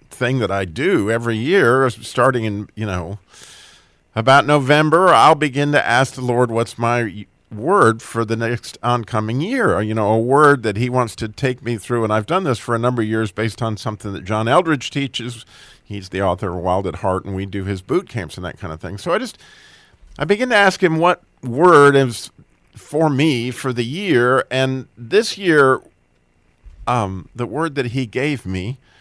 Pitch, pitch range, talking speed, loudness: 120 Hz, 105-135 Hz, 200 wpm, -17 LUFS